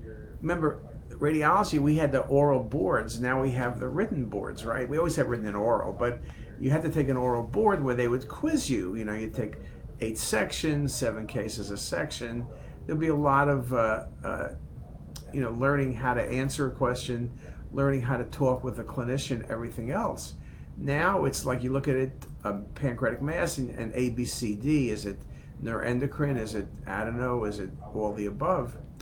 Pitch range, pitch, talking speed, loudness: 115-140 Hz, 130 Hz, 190 wpm, -29 LUFS